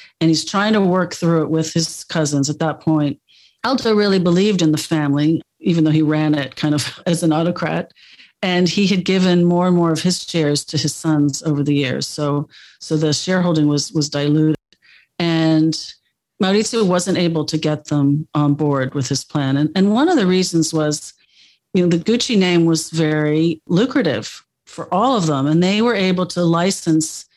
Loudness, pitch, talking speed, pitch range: -17 LUFS, 160 Hz, 195 wpm, 150-180 Hz